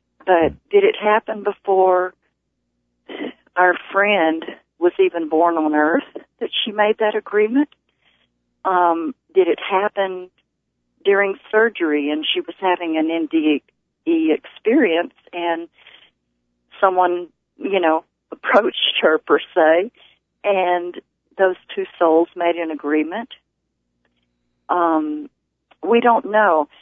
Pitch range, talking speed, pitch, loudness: 155-205 Hz, 110 wpm, 175 Hz, -18 LUFS